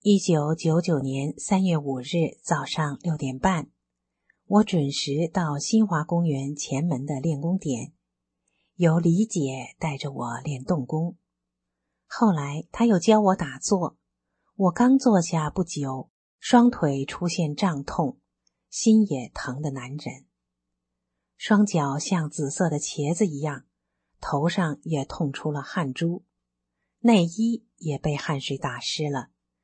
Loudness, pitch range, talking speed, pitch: -25 LUFS, 135-180 Hz, 180 characters per minute, 150 Hz